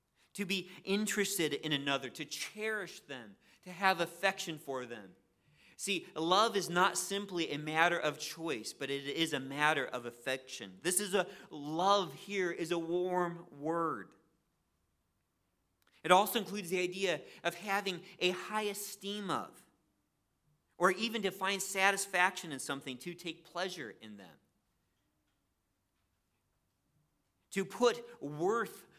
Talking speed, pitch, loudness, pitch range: 130 wpm, 170 Hz, -35 LUFS, 135-195 Hz